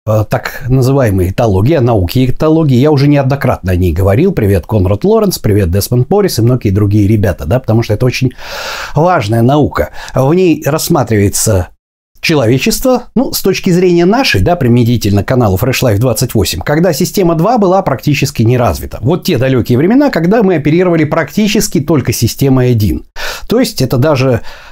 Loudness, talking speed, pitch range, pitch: -10 LUFS, 160 wpm, 110-165 Hz, 130 Hz